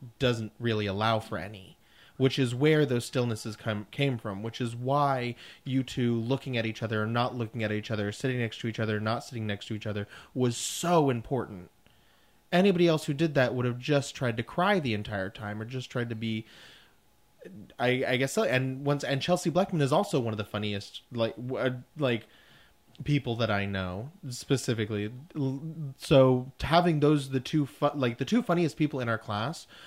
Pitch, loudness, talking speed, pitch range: 125 Hz, -29 LUFS, 195 wpm, 110-140 Hz